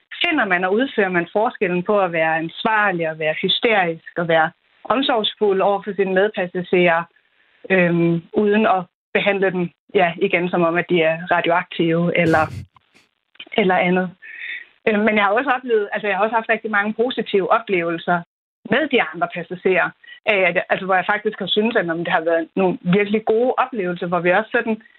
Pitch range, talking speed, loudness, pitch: 175-215 Hz, 180 wpm, -19 LUFS, 190 Hz